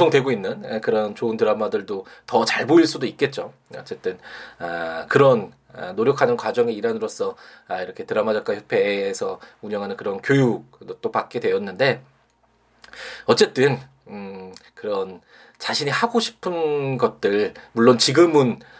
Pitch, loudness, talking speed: 240 Hz, -21 LUFS, 285 characters per minute